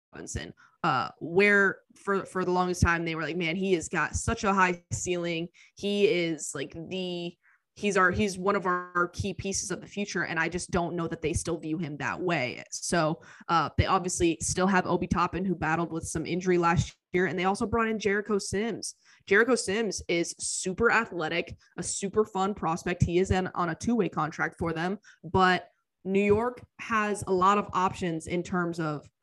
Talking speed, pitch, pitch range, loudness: 200 wpm, 180 Hz, 165-195 Hz, -28 LUFS